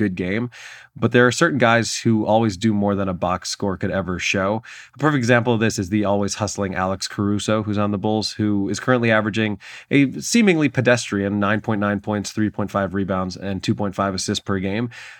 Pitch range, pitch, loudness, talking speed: 100-115 Hz, 105 Hz, -20 LUFS, 195 wpm